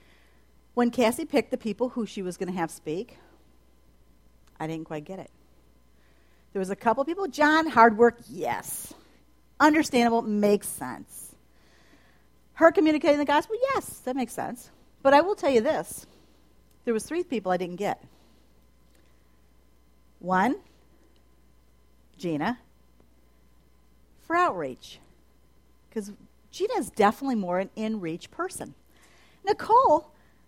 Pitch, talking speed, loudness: 185 Hz, 125 wpm, -26 LUFS